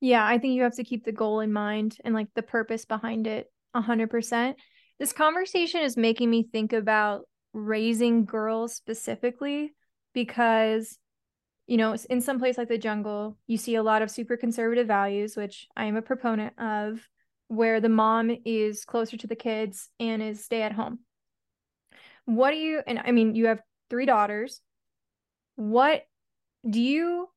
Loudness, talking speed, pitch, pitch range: -27 LUFS, 170 wpm, 230 Hz, 220-245 Hz